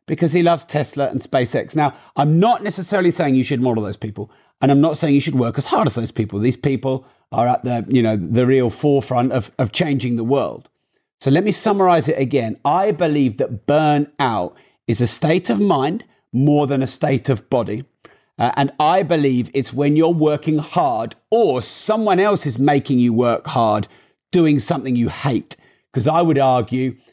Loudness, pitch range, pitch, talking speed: -18 LUFS, 125-160 Hz, 140 Hz, 195 wpm